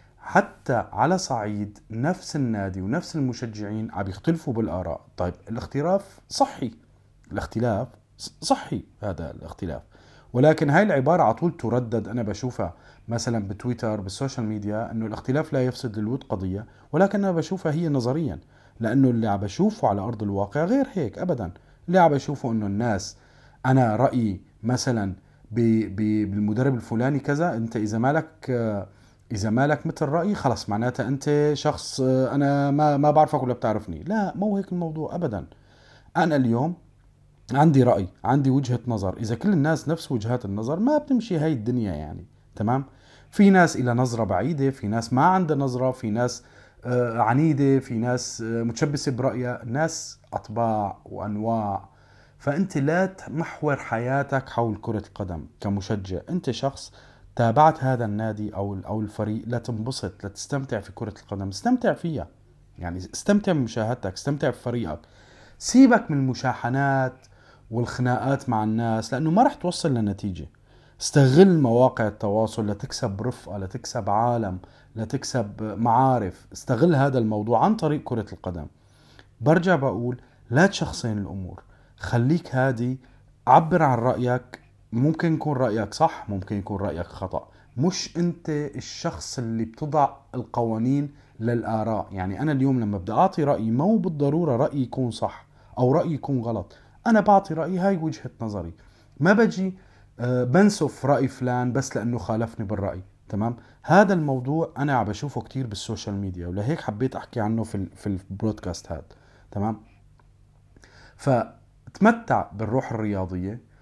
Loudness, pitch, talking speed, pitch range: -24 LUFS, 125 Hz, 135 wpm, 110-145 Hz